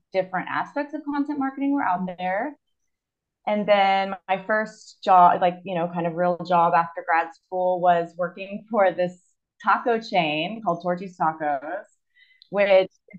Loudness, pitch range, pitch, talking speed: -23 LUFS, 175-210 Hz, 185 Hz, 150 wpm